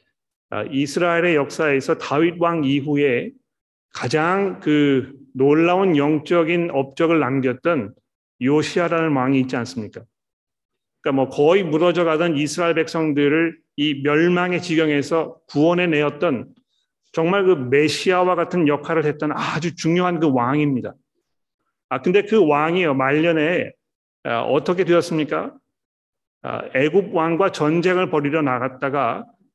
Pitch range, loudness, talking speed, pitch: 145-170 Hz, -19 LUFS, 275 characters per minute, 160 Hz